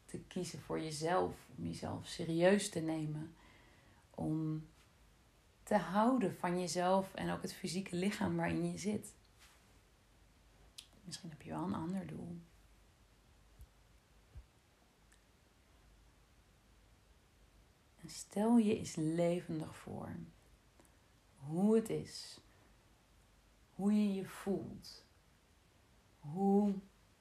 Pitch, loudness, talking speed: 160 Hz, -38 LUFS, 95 wpm